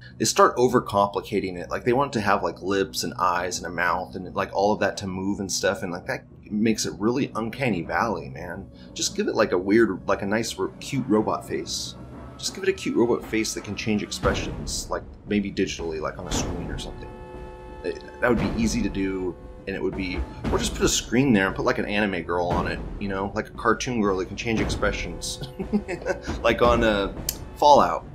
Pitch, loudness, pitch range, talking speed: 100 Hz, -25 LUFS, 85-110 Hz, 230 wpm